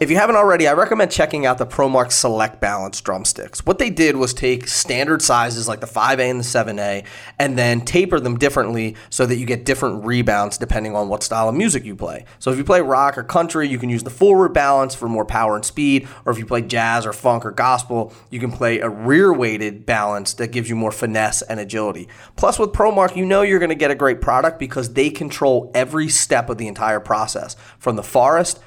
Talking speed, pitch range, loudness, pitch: 230 wpm, 110-140 Hz, -18 LUFS, 125 Hz